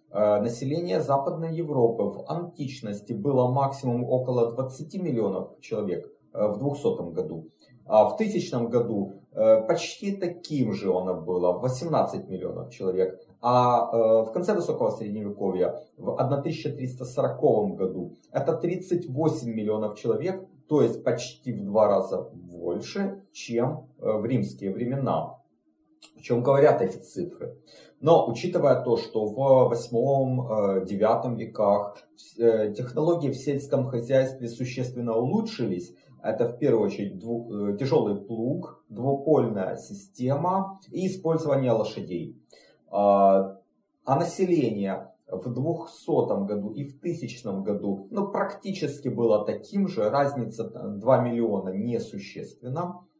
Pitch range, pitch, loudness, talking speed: 110-165 Hz, 130 Hz, -26 LUFS, 110 wpm